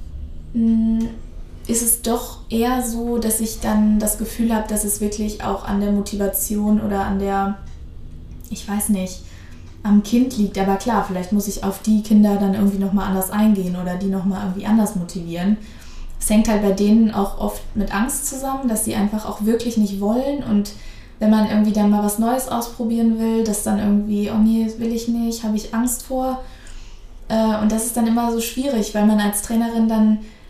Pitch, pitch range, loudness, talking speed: 215 Hz, 200-230 Hz, -19 LUFS, 195 wpm